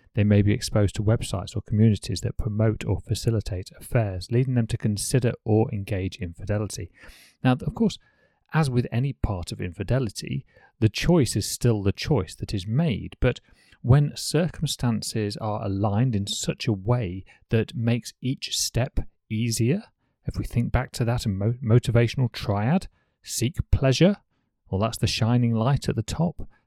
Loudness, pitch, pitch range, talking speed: -25 LUFS, 115 Hz, 105-125 Hz, 155 wpm